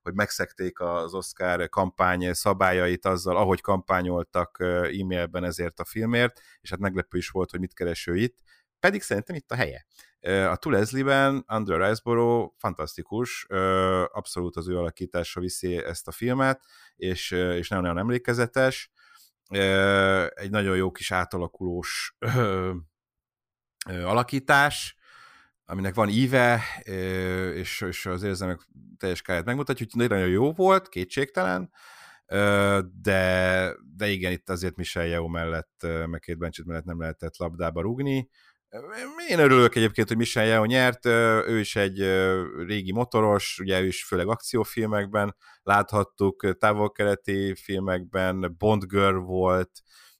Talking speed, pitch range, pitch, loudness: 125 wpm, 90-110 Hz, 95 Hz, -25 LUFS